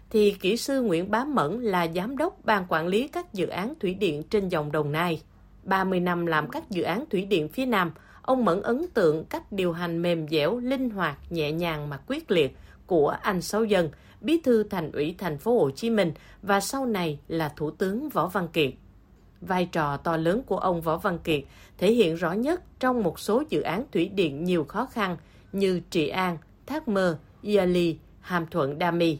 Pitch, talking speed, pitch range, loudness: 185 Hz, 210 wpm, 165-220 Hz, -26 LUFS